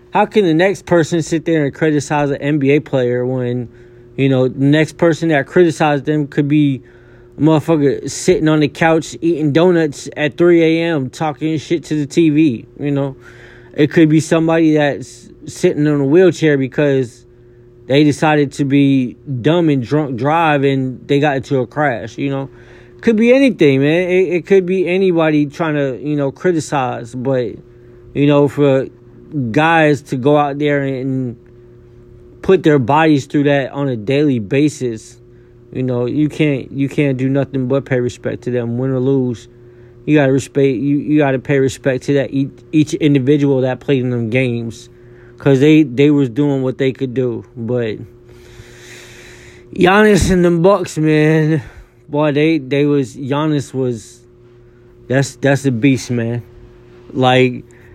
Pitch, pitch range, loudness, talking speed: 140 Hz, 120-155 Hz, -15 LUFS, 165 wpm